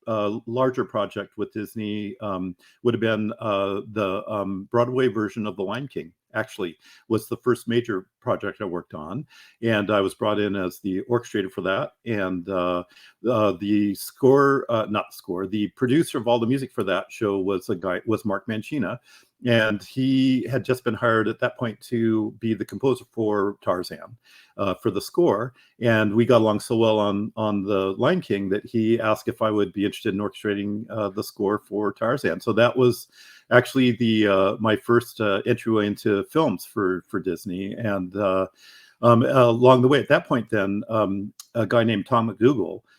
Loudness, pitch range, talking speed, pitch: -23 LUFS, 100-120 Hz, 190 wpm, 110 Hz